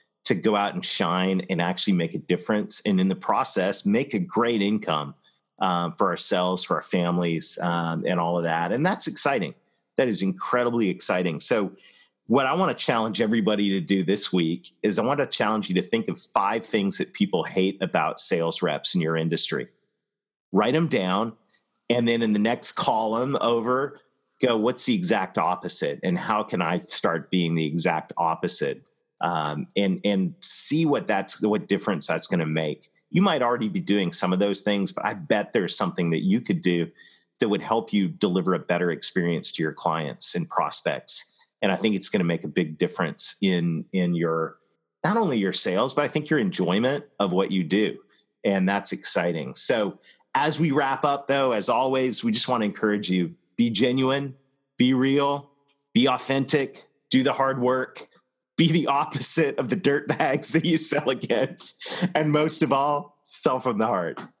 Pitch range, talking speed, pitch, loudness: 90-135 Hz, 190 wpm, 105 Hz, -23 LUFS